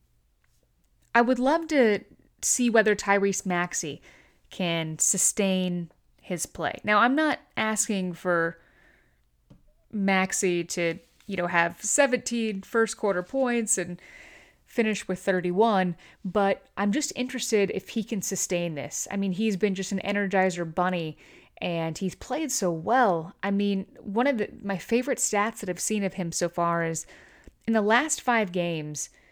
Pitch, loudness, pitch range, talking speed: 195 Hz, -26 LUFS, 175-220 Hz, 150 wpm